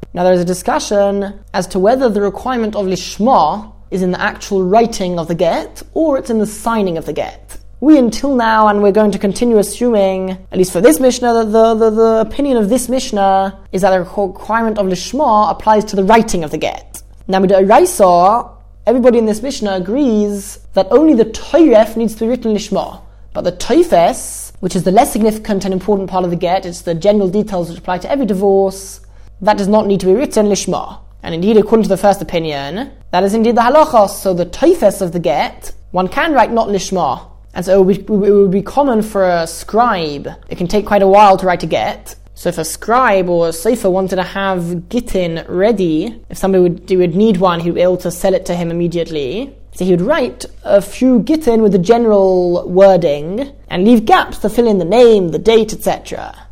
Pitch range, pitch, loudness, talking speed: 185-225 Hz, 200 Hz, -13 LUFS, 220 wpm